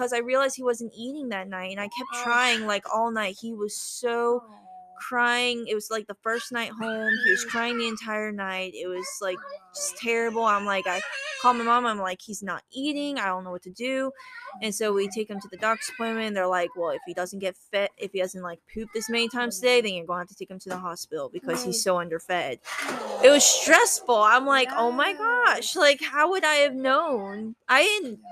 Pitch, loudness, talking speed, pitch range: 225 Hz, -25 LUFS, 235 wpm, 195-250 Hz